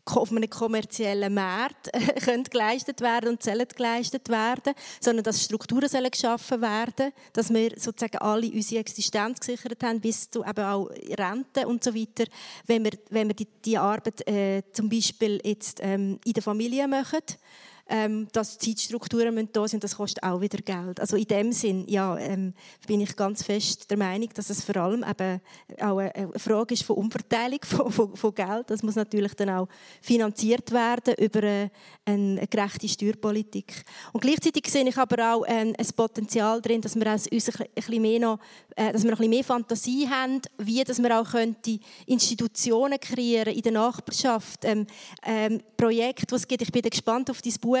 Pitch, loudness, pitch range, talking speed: 225 Hz, -26 LUFS, 205-235 Hz, 175 wpm